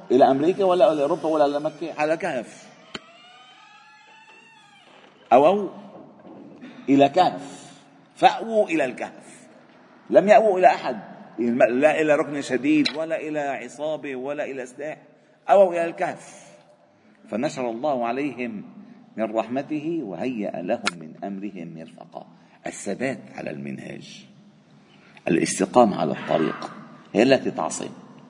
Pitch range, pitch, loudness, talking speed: 140-230 Hz, 155 Hz, -22 LUFS, 115 wpm